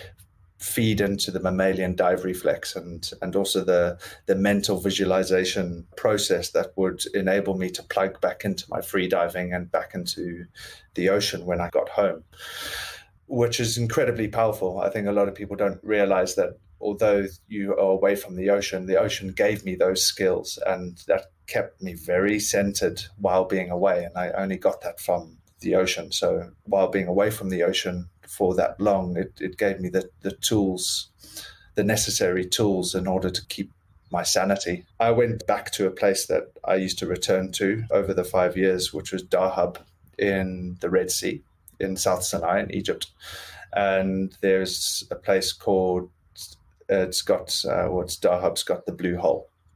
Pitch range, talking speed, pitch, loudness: 90-100 Hz, 175 wpm, 95 Hz, -24 LUFS